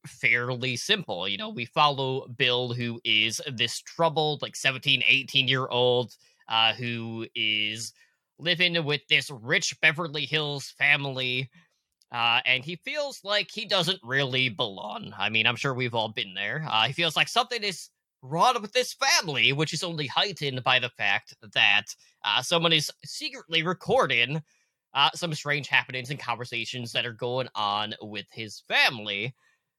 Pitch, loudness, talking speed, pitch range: 135 Hz, -25 LUFS, 160 wpm, 120-160 Hz